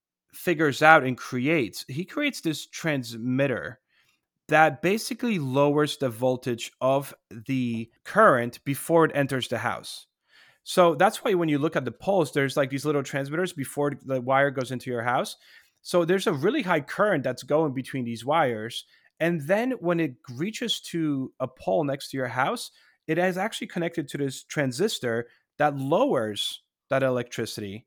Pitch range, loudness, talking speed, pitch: 130-165 Hz, -25 LUFS, 165 wpm, 140 Hz